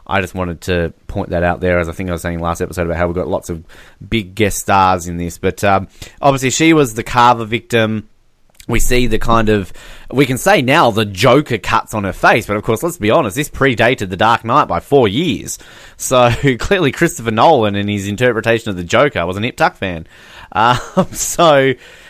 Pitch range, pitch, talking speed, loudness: 90-125 Hz, 110 Hz, 225 wpm, -14 LUFS